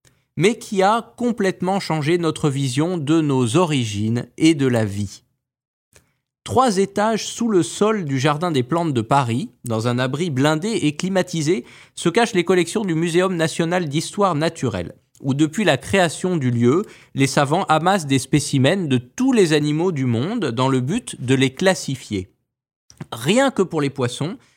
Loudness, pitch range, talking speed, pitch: -20 LUFS, 135-185 Hz, 165 wpm, 160 Hz